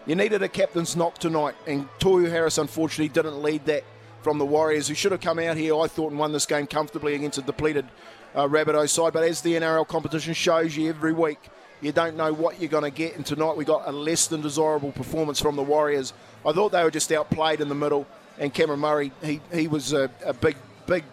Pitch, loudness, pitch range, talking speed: 155 Hz, -24 LUFS, 145-165 Hz, 235 wpm